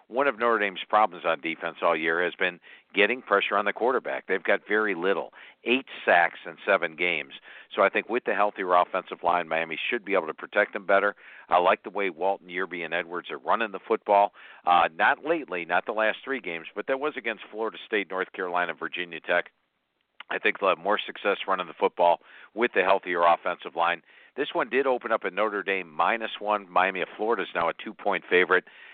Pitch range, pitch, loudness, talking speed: 85-100 Hz, 90 Hz, -26 LUFS, 215 wpm